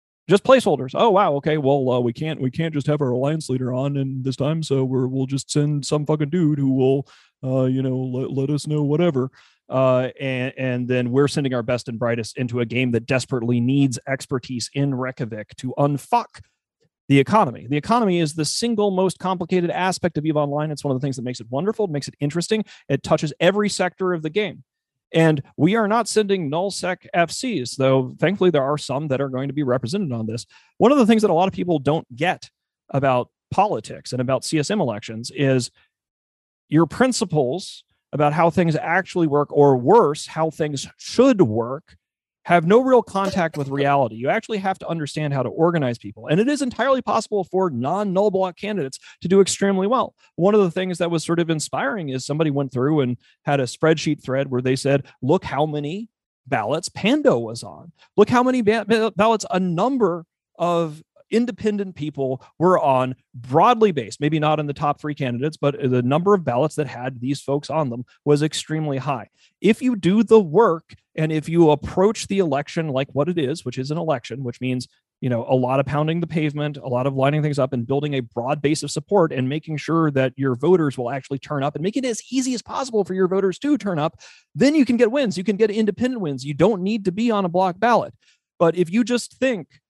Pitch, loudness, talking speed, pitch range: 150 Hz, -21 LUFS, 220 wpm, 130-190 Hz